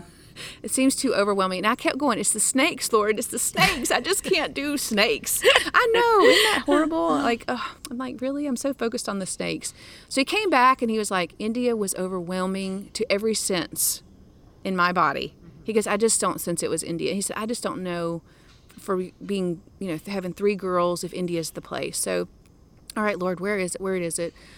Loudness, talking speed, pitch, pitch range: -23 LUFS, 220 wpm, 205 Hz, 180-255 Hz